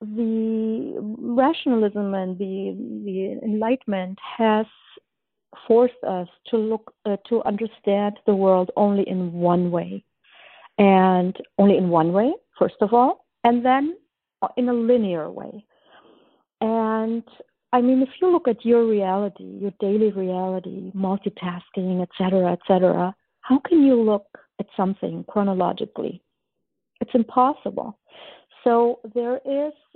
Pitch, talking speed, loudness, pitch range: 215 Hz, 125 wpm, -22 LUFS, 190-240 Hz